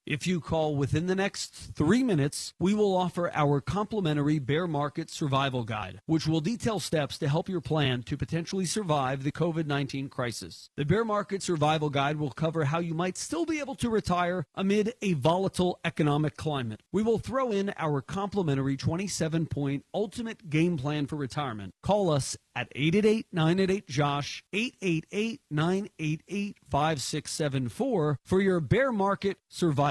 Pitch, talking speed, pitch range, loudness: 160 Hz, 145 wpm, 145-190 Hz, -29 LUFS